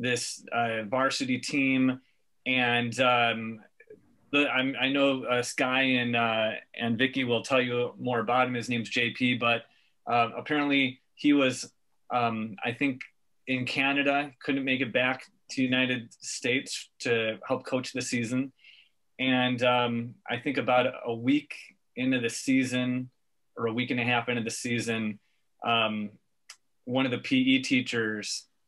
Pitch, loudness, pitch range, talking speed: 125 Hz, -28 LUFS, 120-130 Hz, 150 wpm